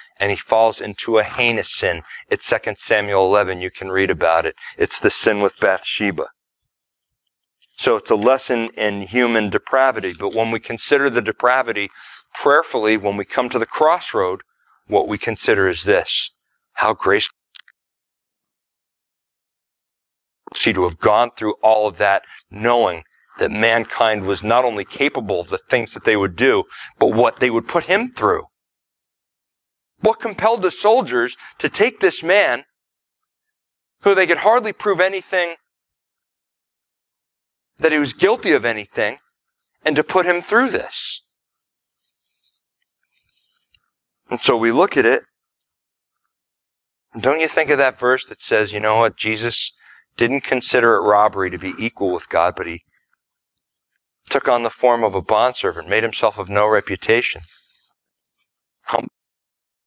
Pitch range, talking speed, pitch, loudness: 105-175 Hz, 145 wpm, 120 Hz, -18 LUFS